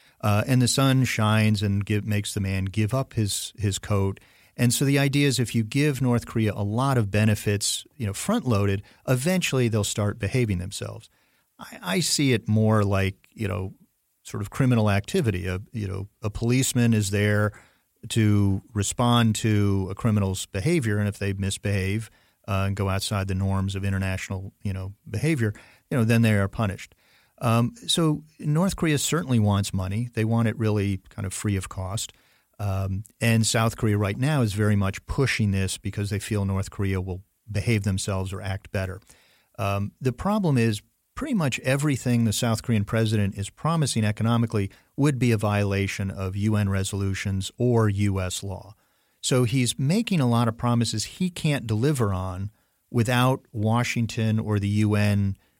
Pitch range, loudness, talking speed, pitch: 100-120 Hz, -25 LUFS, 175 wpm, 105 Hz